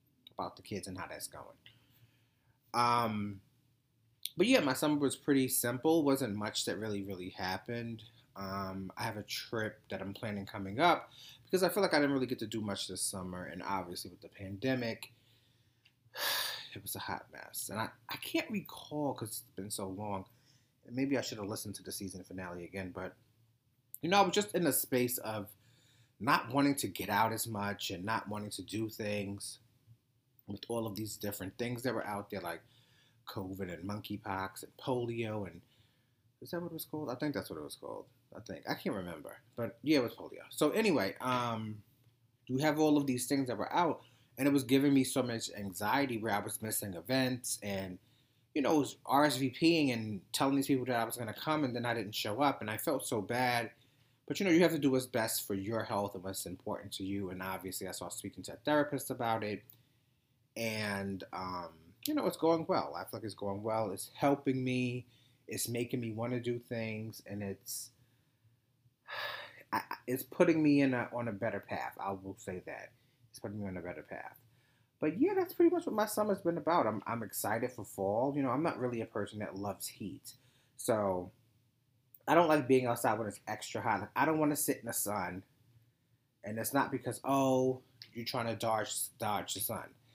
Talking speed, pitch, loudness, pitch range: 210 wpm, 120 Hz, -35 LUFS, 100-130 Hz